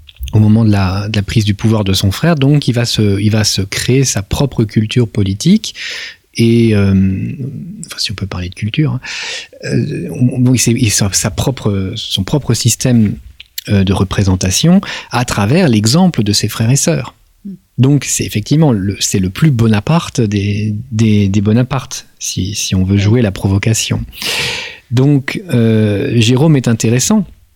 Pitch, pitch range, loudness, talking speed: 115 Hz, 100-130 Hz, -13 LUFS, 165 wpm